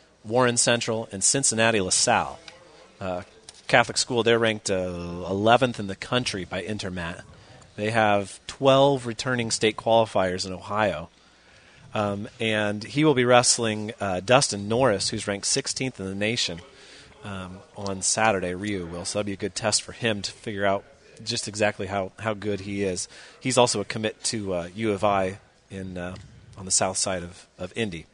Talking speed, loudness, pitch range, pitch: 175 wpm, -24 LUFS, 95-115 Hz, 105 Hz